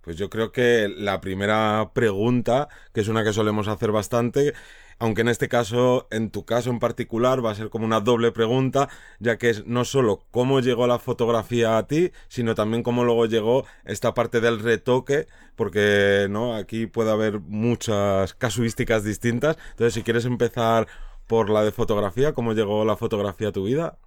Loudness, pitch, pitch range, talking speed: -23 LUFS, 115 Hz, 110-120 Hz, 180 wpm